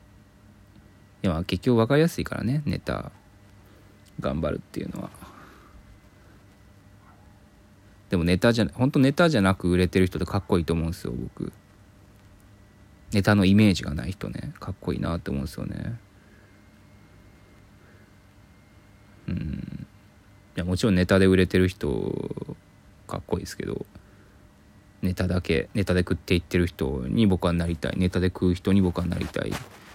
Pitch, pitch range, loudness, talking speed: 100 Hz, 90-100 Hz, -25 LUFS, 290 characters per minute